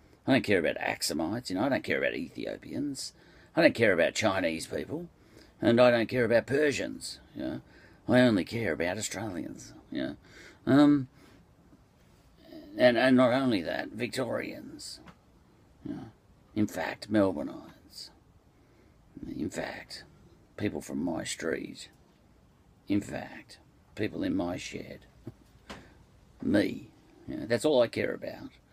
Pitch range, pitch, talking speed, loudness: 115-150 Hz, 130 Hz, 135 wpm, -29 LUFS